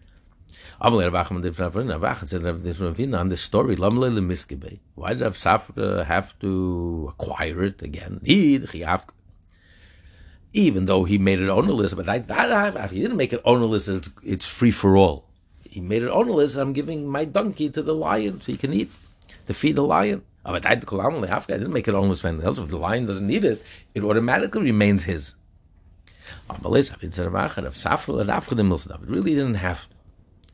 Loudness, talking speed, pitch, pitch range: -23 LUFS, 155 wpm, 95 Hz, 90-110 Hz